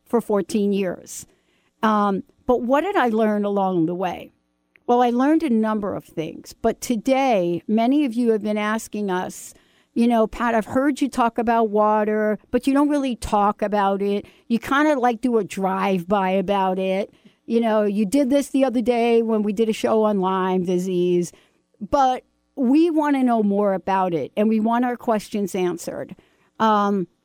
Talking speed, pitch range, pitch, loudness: 185 wpm, 195-245 Hz, 220 Hz, -21 LUFS